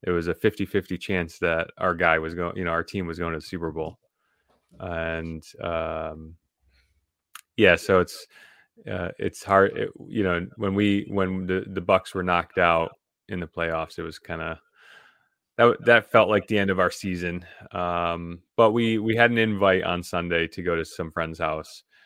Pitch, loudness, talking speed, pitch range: 90 Hz, -24 LUFS, 195 wpm, 85-100 Hz